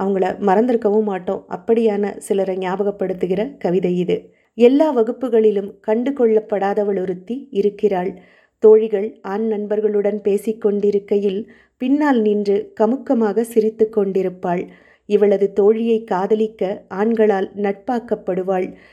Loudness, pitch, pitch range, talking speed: -18 LUFS, 210 Hz, 195-220 Hz, 90 wpm